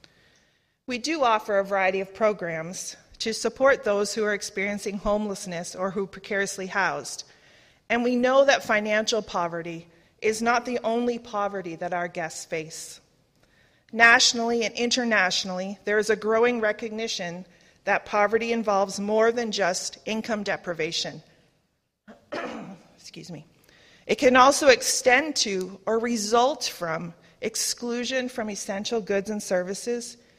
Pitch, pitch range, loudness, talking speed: 210 Hz, 185-235 Hz, -24 LUFS, 130 wpm